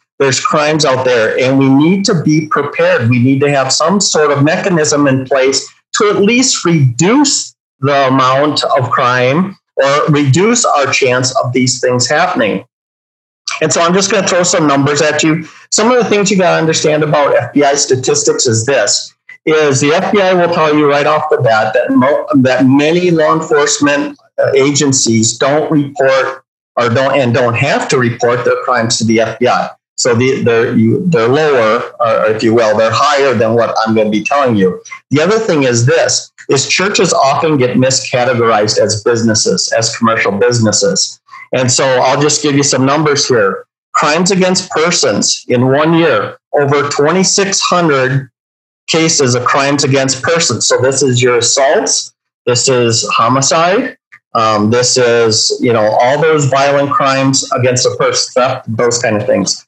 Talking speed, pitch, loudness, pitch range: 175 wpm, 140 Hz, -10 LUFS, 125-160 Hz